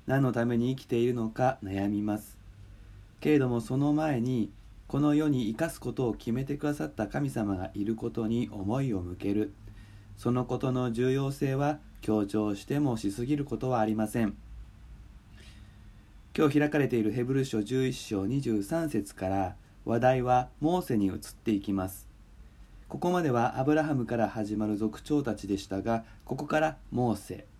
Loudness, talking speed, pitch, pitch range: -30 LUFS, 310 characters per minute, 115 Hz, 105-130 Hz